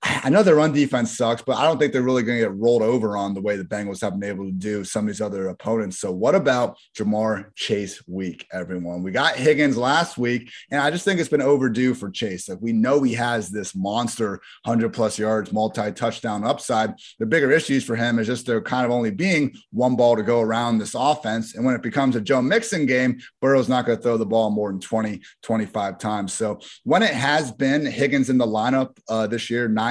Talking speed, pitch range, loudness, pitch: 235 wpm, 105-130 Hz, -22 LUFS, 115 Hz